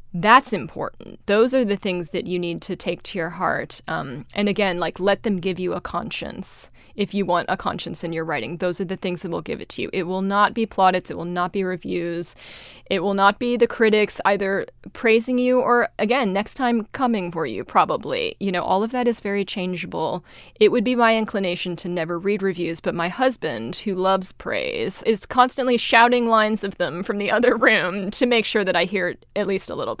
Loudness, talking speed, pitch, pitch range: -21 LUFS, 230 wpm, 200 Hz, 180-235 Hz